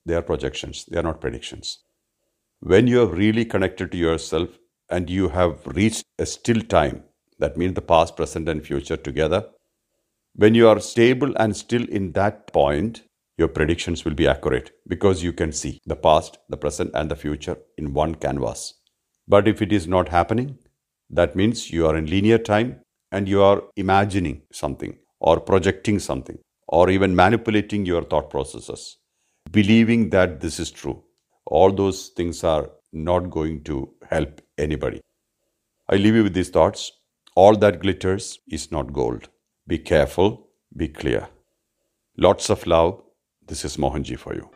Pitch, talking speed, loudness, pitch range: 95 Hz, 165 wpm, -21 LUFS, 85-105 Hz